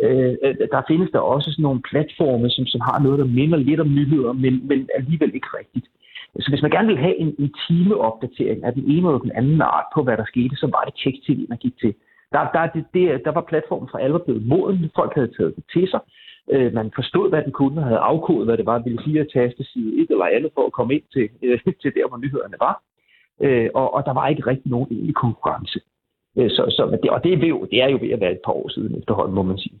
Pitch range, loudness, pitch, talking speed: 125-155 Hz, -20 LUFS, 140 Hz, 260 wpm